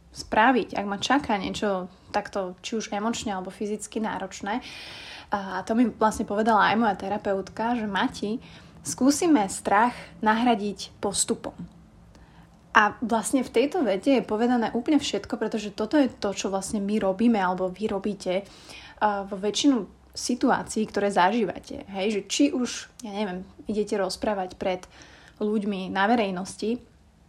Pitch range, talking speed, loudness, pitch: 195-235 Hz, 140 wpm, -26 LUFS, 210 Hz